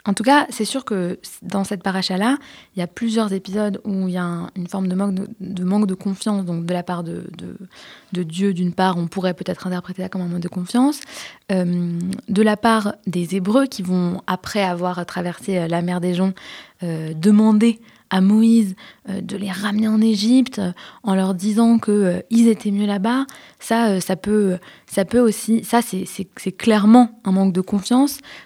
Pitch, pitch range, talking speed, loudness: 195 Hz, 185-220 Hz, 200 wpm, -19 LUFS